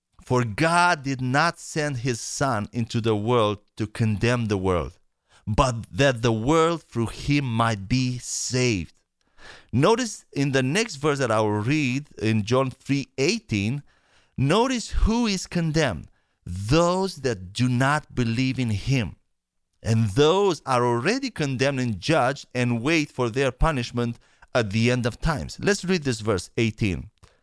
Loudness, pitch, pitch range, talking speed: -24 LUFS, 125 Hz, 115-150 Hz, 150 wpm